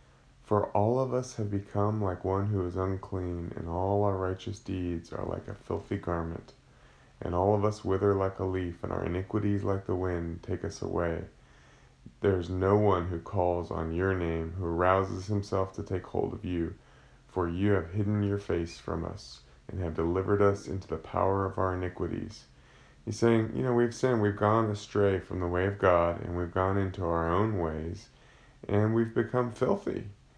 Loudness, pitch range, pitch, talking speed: -30 LUFS, 90-105 Hz, 95 Hz, 195 wpm